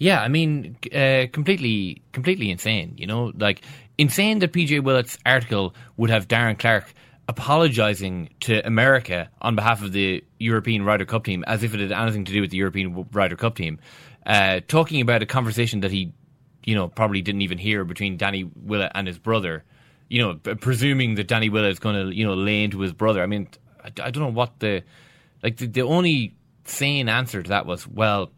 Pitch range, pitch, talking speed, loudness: 100-130 Hz, 110 Hz, 200 wpm, -22 LUFS